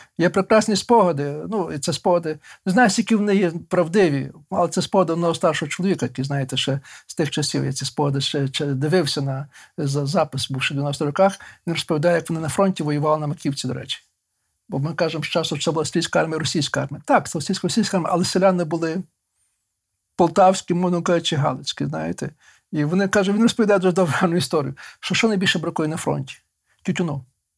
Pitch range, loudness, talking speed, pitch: 145-185 Hz, -21 LUFS, 190 wpm, 165 Hz